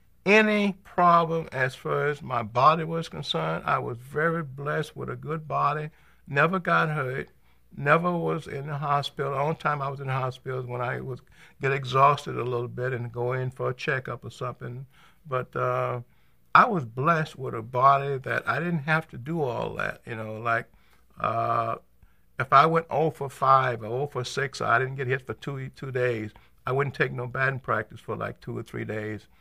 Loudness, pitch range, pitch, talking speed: -26 LUFS, 125-155 Hz, 135 Hz, 205 wpm